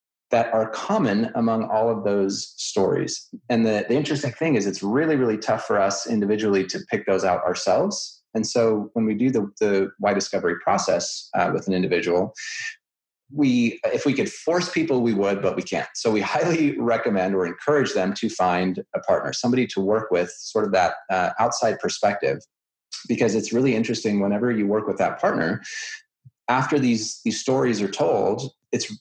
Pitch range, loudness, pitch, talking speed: 100-130 Hz, -23 LUFS, 110 Hz, 185 wpm